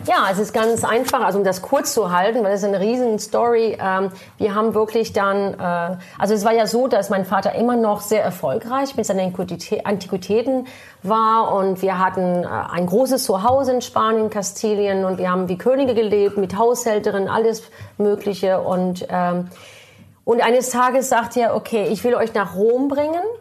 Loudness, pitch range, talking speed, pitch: -19 LUFS, 195-235 Hz, 175 wpm, 215 Hz